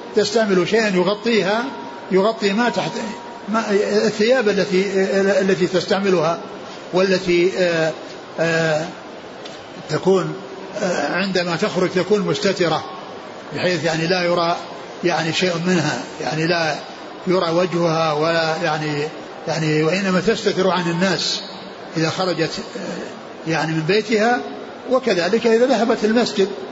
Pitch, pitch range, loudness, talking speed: 185 Hz, 165-205 Hz, -19 LUFS, 100 wpm